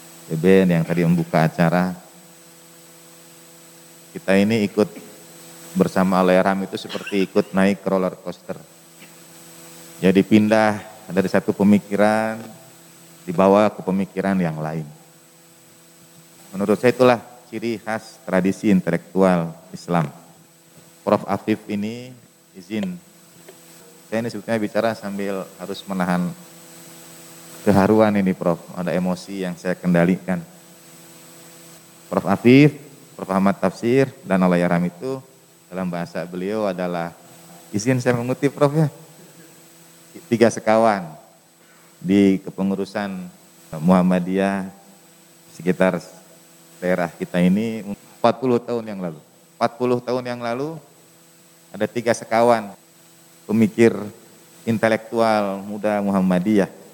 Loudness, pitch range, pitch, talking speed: -20 LUFS, 85-110 Hz, 95 Hz, 100 wpm